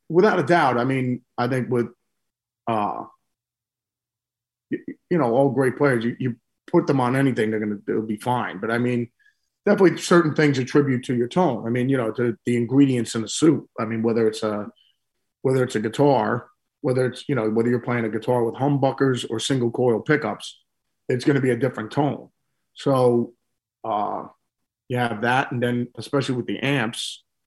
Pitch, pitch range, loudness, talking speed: 125 Hz, 115-135 Hz, -22 LUFS, 190 wpm